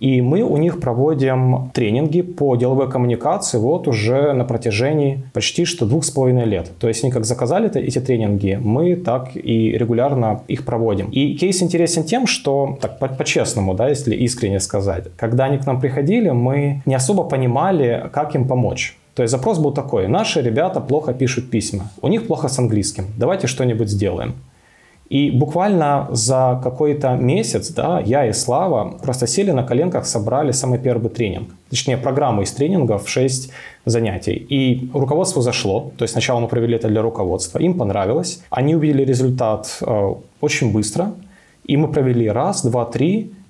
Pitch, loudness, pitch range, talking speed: 130 Hz, -18 LUFS, 115-145 Hz, 165 wpm